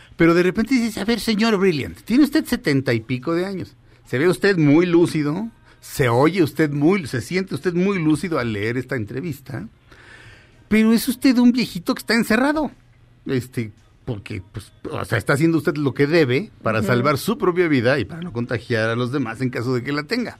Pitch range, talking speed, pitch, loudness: 120-195 Hz, 205 wpm, 150 Hz, -20 LUFS